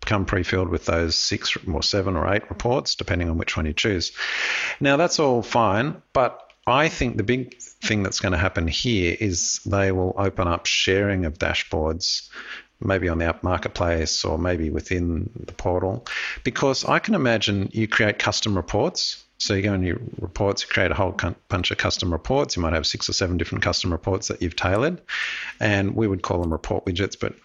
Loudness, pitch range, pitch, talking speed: -23 LUFS, 90-110 Hz, 95 Hz, 200 wpm